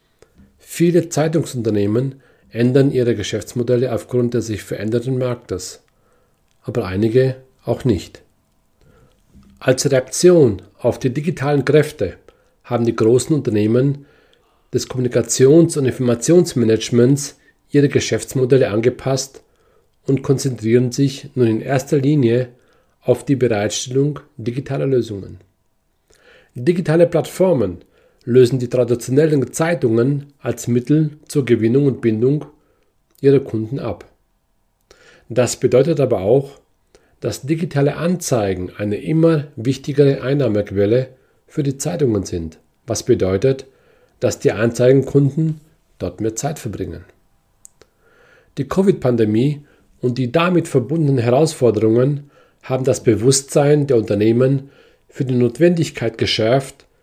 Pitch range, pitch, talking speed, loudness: 115-145 Hz, 130 Hz, 105 wpm, -17 LUFS